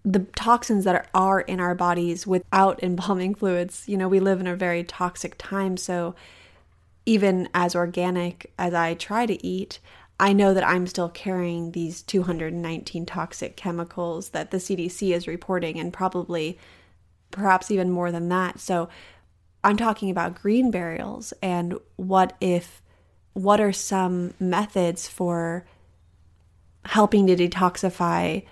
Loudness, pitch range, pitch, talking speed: -24 LUFS, 170-190 Hz, 180 Hz, 140 wpm